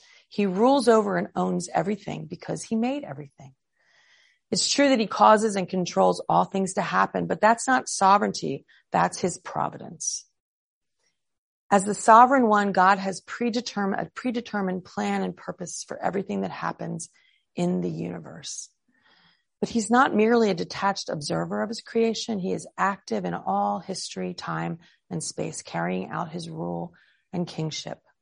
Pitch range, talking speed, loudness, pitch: 175-225 Hz, 155 wpm, -25 LUFS, 200 Hz